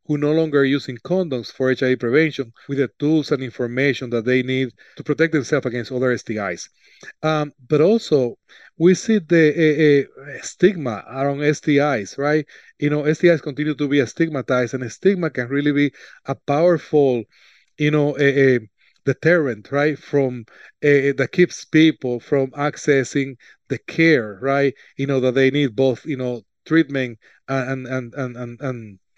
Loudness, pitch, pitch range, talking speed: -19 LUFS, 140 Hz, 130-150 Hz, 160 wpm